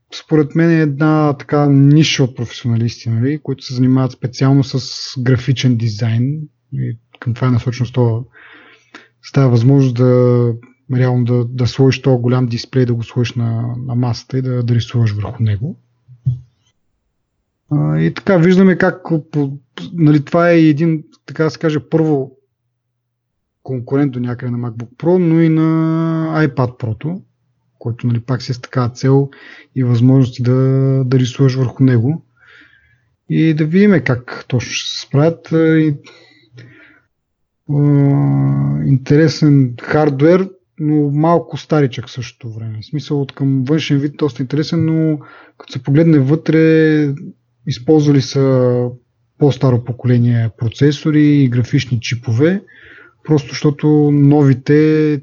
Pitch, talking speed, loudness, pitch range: 135 Hz, 130 wpm, -14 LUFS, 120-150 Hz